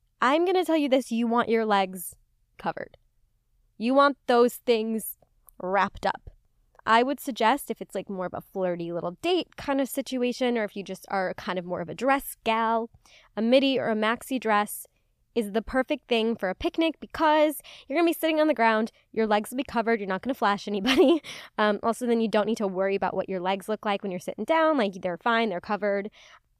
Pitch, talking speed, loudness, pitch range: 225 Hz, 220 wpm, -26 LUFS, 200-265 Hz